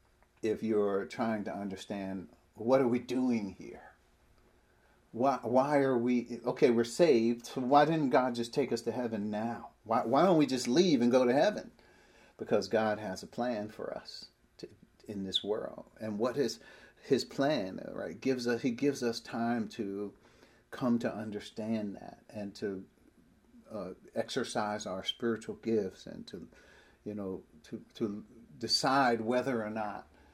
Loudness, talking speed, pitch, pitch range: -32 LUFS, 160 wpm, 115 Hz, 105-125 Hz